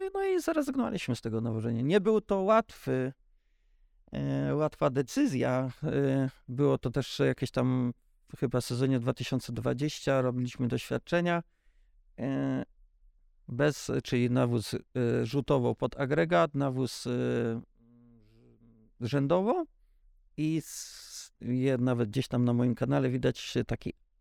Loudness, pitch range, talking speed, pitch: -30 LUFS, 120-145 Hz, 100 wpm, 130 Hz